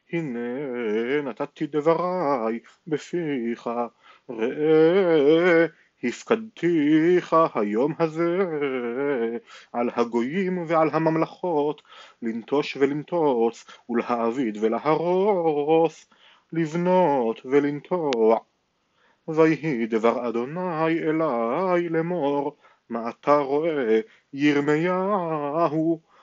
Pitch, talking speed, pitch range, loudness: 150 Hz, 60 wpm, 120-165 Hz, -23 LUFS